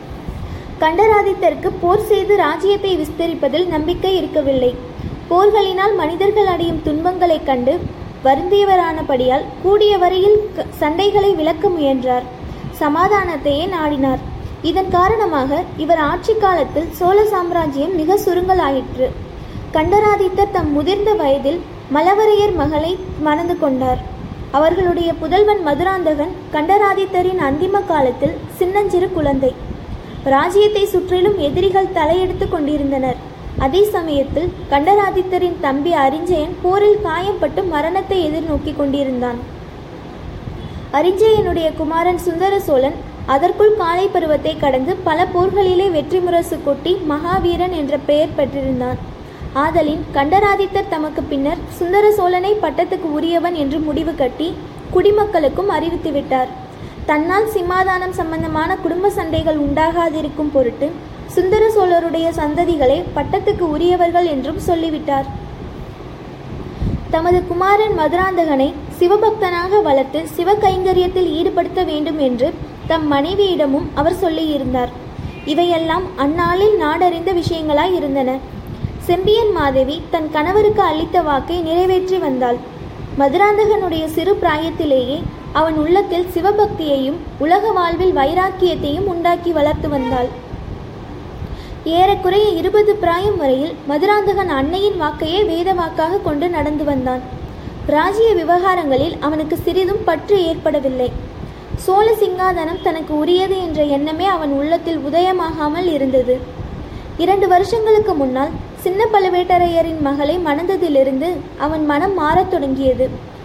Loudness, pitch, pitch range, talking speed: -16 LUFS, 340 Hz, 300-380 Hz, 95 wpm